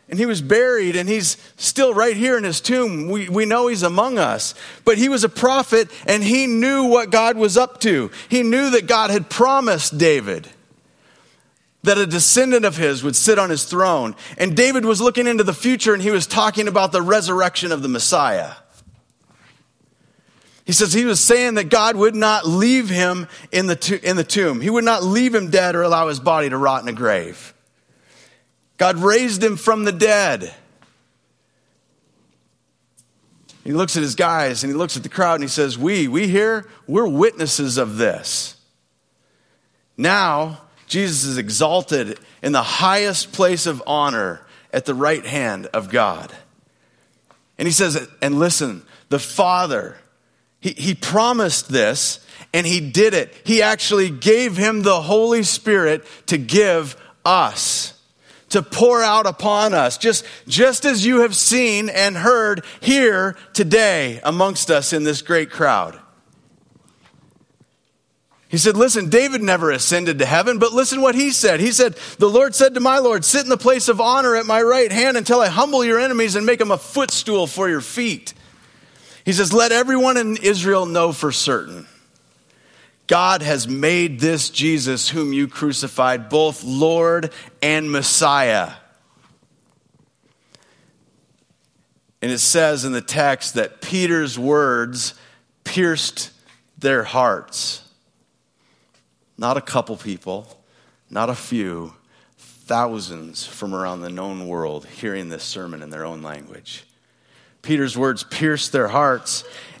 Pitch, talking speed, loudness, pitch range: 185 Hz, 155 wpm, -17 LUFS, 150-225 Hz